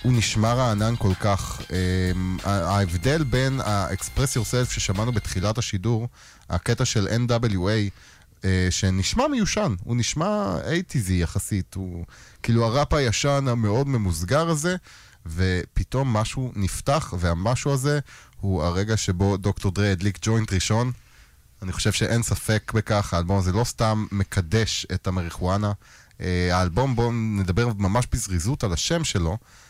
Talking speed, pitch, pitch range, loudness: 125 wpm, 105 Hz, 95-120 Hz, -24 LUFS